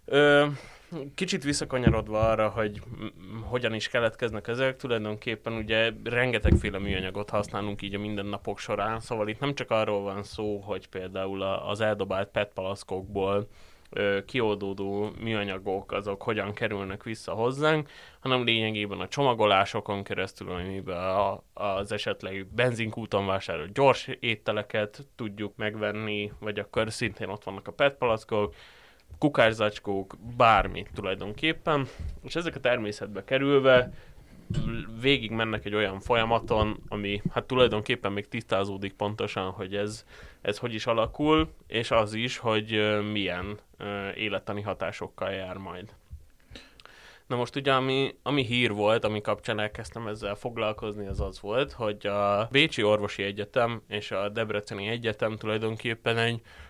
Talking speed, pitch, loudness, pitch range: 125 wpm, 105 Hz, -28 LUFS, 100-115 Hz